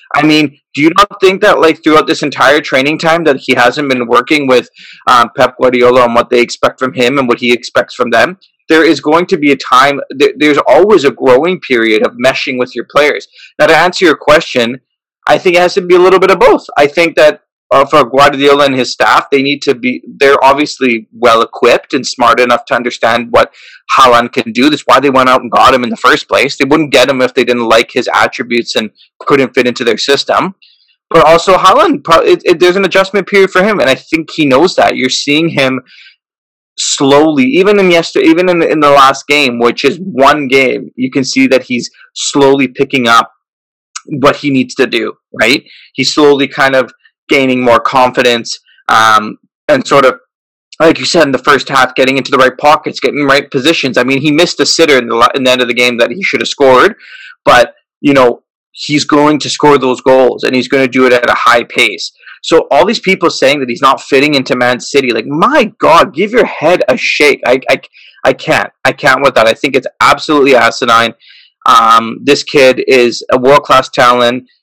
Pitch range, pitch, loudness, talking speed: 125-155 Hz, 140 Hz, -8 LUFS, 220 wpm